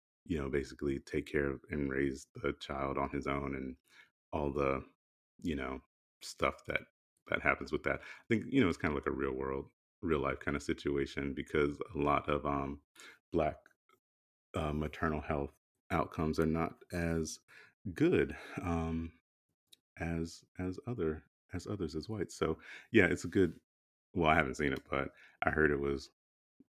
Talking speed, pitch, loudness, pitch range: 175 wpm, 70 Hz, -36 LUFS, 70-80 Hz